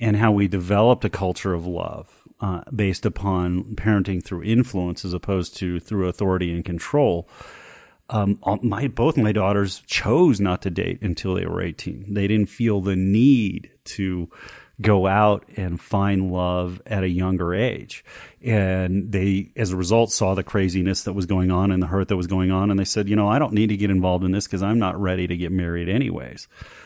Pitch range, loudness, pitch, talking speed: 90-105 Hz, -22 LUFS, 95 Hz, 200 wpm